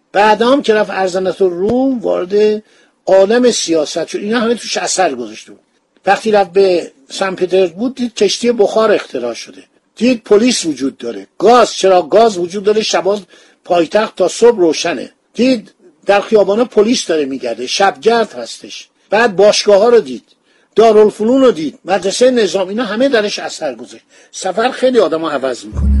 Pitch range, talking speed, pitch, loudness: 190-240 Hz, 160 wpm, 210 Hz, -13 LUFS